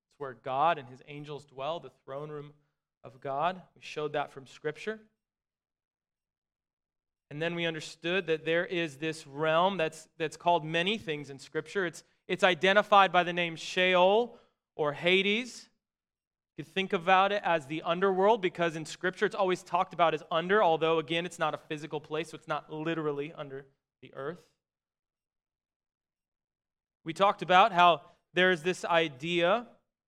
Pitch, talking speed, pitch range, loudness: 165 Hz, 160 wpm, 155-185 Hz, -29 LUFS